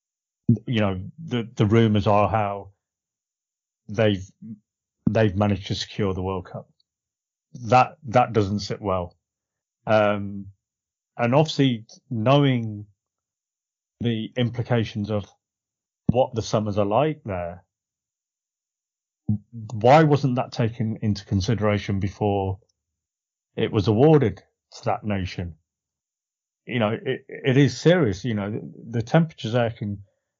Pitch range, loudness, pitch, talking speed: 100-120 Hz, -23 LUFS, 110 Hz, 115 wpm